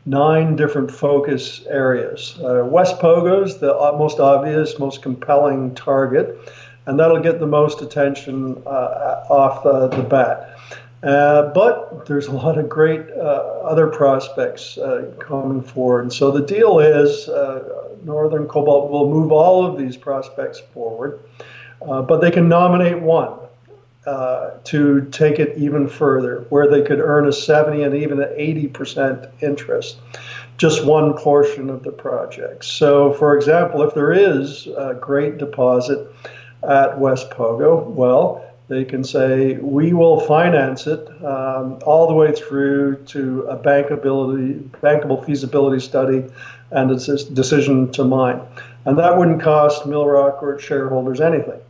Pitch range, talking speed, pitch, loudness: 135-155 Hz, 150 wpm, 145 Hz, -16 LUFS